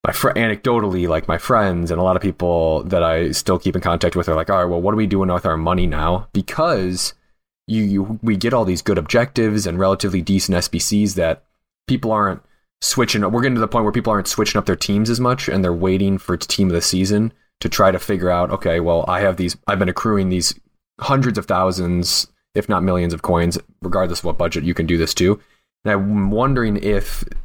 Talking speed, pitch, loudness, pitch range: 235 wpm, 95 Hz, -18 LUFS, 90-105 Hz